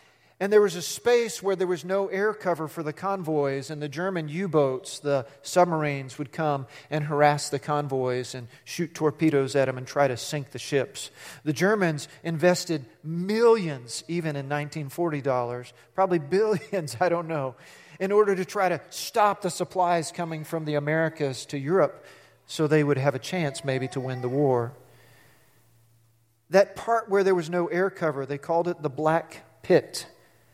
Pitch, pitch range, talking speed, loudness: 155 Hz, 140-180 Hz, 175 wpm, -26 LUFS